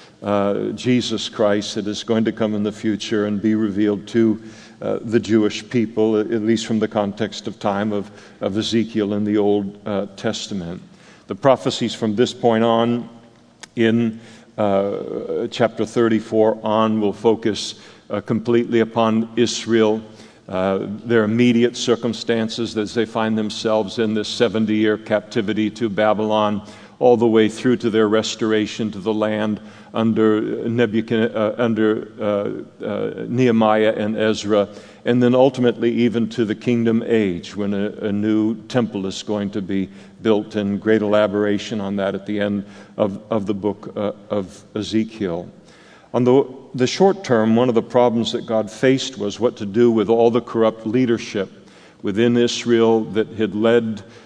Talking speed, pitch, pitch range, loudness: 160 wpm, 110 Hz, 105-115 Hz, -20 LUFS